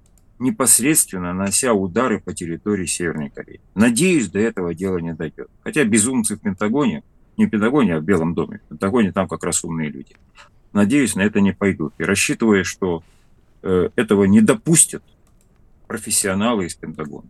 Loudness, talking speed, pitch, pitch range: -18 LUFS, 160 wpm, 100 Hz, 85-130 Hz